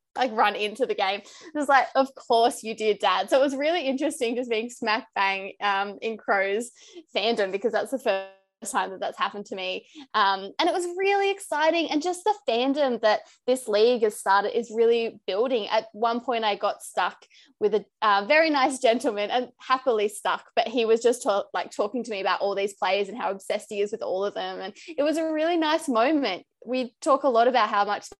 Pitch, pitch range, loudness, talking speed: 235 Hz, 205-290 Hz, -25 LUFS, 225 wpm